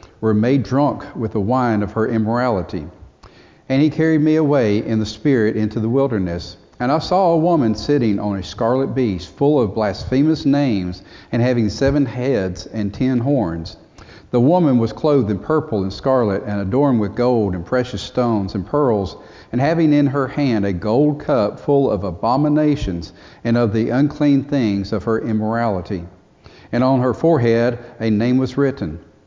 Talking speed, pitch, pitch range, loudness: 175 wpm, 115 Hz, 100-140 Hz, -18 LUFS